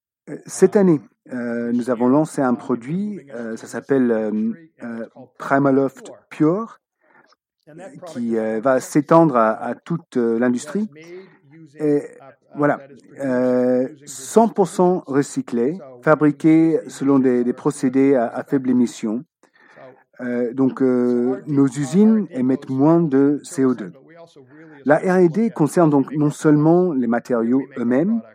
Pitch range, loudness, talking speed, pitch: 125-160 Hz, -19 LUFS, 120 wpm, 140 Hz